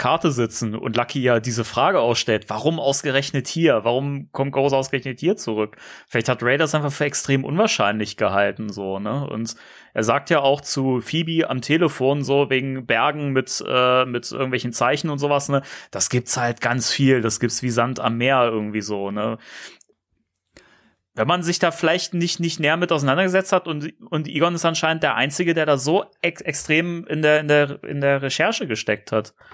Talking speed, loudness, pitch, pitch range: 190 wpm, -21 LUFS, 135 Hz, 120-155 Hz